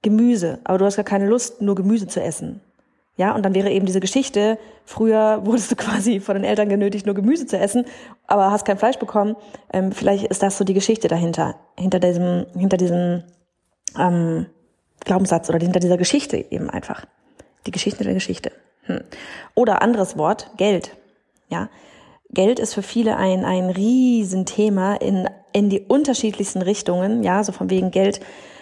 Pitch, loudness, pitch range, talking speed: 200 Hz, -20 LUFS, 185-220 Hz, 170 wpm